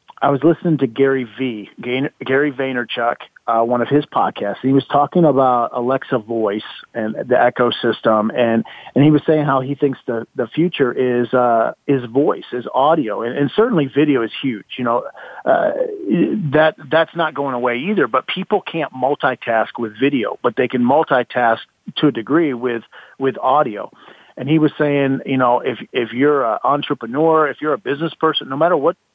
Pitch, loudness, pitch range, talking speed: 135 Hz, -17 LUFS, 125-150 Hz, 185 wpm